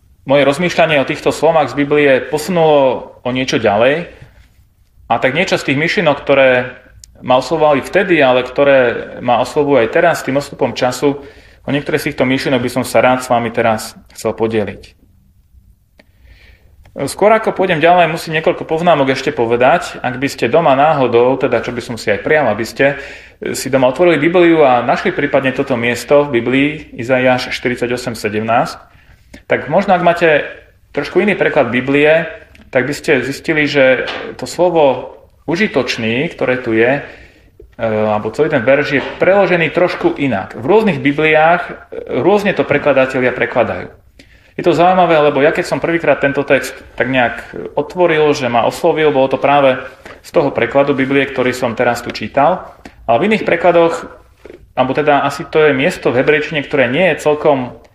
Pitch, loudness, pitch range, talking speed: 140 Hz, -13 LUFS, 125-155 Hz, 165 wpm